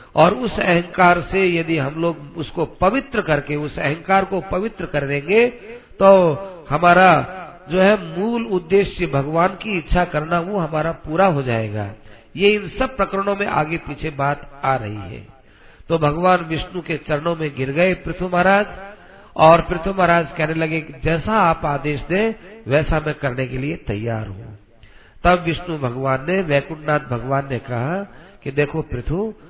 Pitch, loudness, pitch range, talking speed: 165 Hz, -19 LUFS, 145-185 Hz, 160 wpm